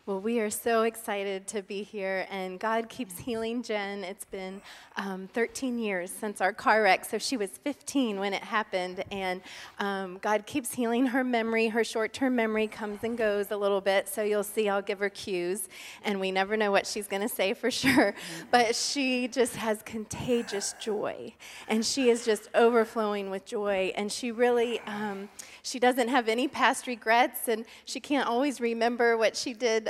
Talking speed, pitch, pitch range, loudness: 190 wpm, 220 Hz, 200-240 Hz, -29 LUFS